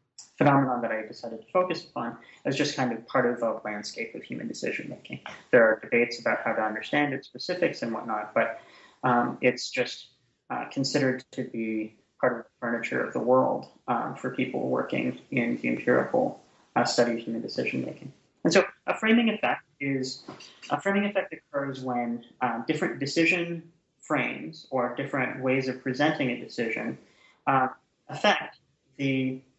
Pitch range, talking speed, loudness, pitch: 120-150 Hz, 170 wpm, -28 LUFS, 130 Hz